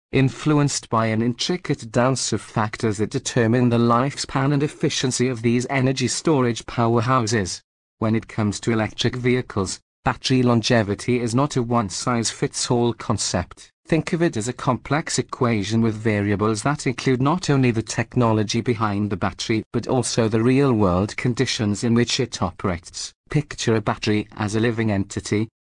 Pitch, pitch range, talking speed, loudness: 120 Hz, 110-130 Hz, 160 wpm, -21 LUFS